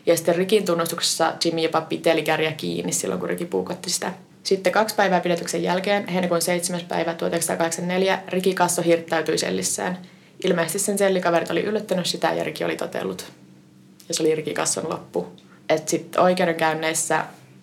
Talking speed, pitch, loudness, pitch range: 150 wpm, 170 Hz, -22 LUFS, 160-180 Hz